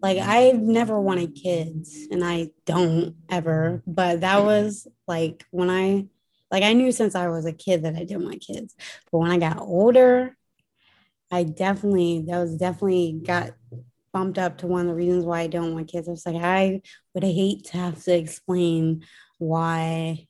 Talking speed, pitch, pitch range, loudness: 185 wpm, 175 Hz, 165-190 Hz, -23 LUFS